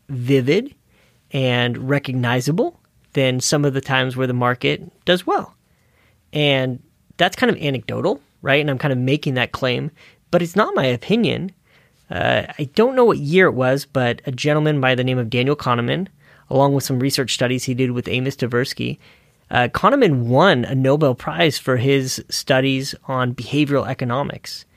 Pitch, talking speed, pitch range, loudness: 135 Hz, 170 wpm, 125-150 Hz, -19 LUFS